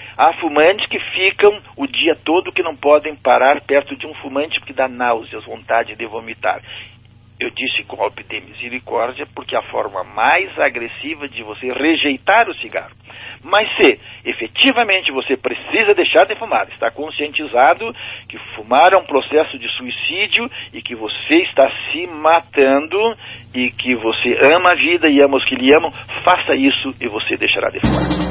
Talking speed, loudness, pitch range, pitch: 165 wpm, -15 LUFS, 125-180 Hz, 145 Hz